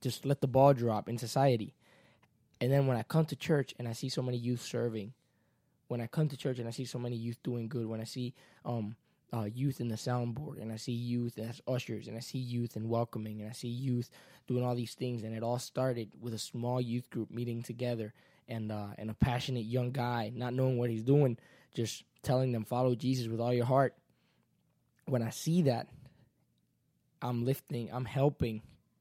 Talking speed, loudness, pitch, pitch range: 215 wpm, -34 LUFS, 120 Hz, 115-130 Hz